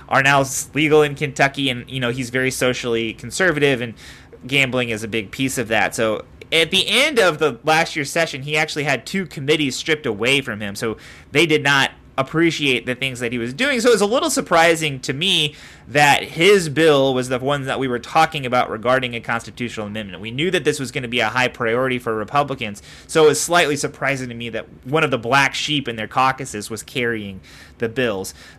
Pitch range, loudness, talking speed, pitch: 120-155 Hz, -18 LUFS, 220 wpm, 135 Hz